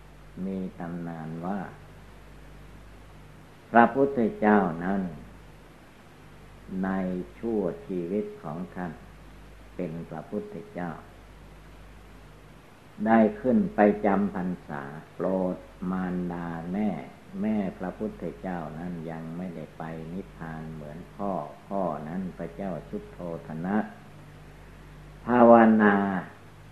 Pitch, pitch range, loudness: 90 Hz, 85-105 Hz, -27 LUFS